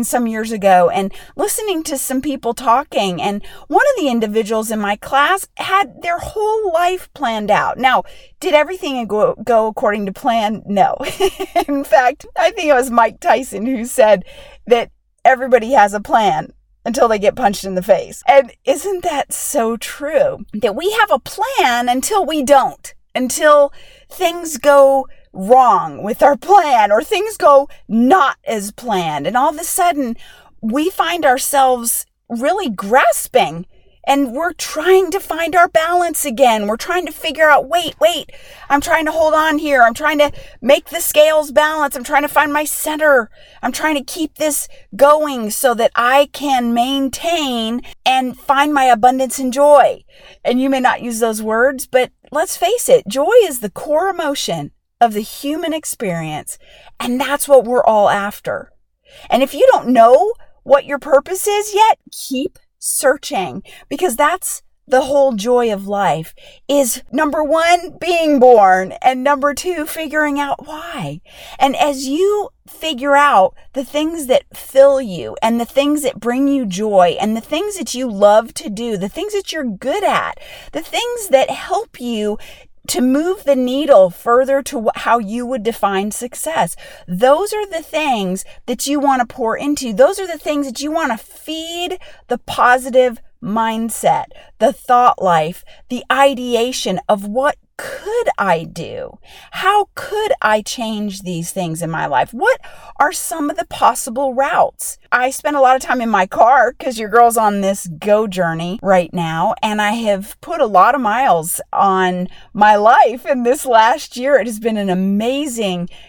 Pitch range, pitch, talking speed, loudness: 230-310 Hz, 275 Hz, 170 wpm, -15 LUFS